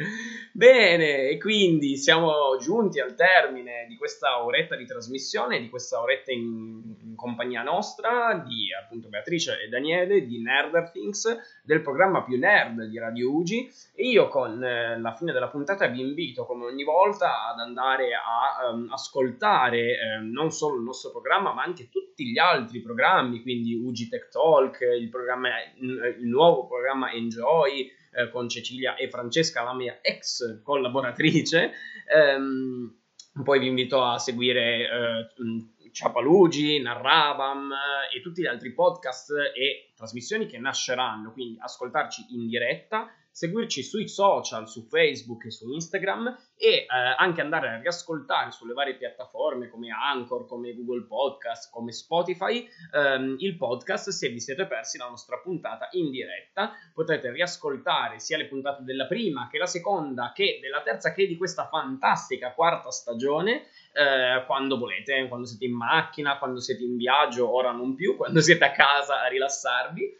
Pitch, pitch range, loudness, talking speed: 135 Hz, 120-175 Hz, -25 LUFS, 155 wpm